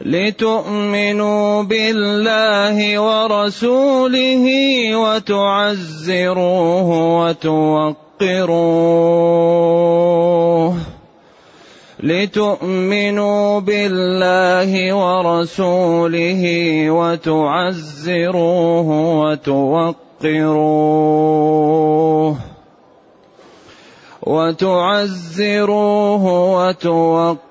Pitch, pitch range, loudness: 180 Hz, 165-205 Hz, -15 LUFS